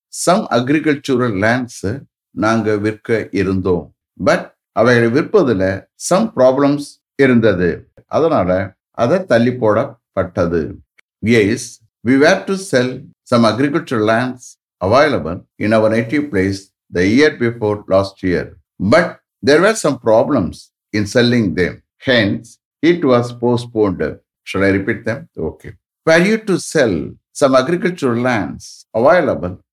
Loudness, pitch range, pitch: -15 LUFS, 105-135 Hz, 120 Hz